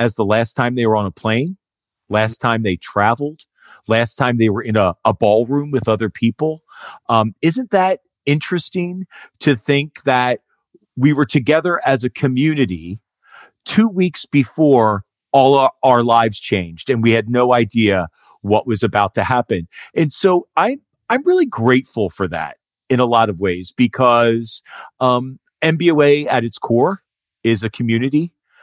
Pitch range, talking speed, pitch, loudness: 110-145 Hz, 160 wpm, 125 Hz, -16 LUFS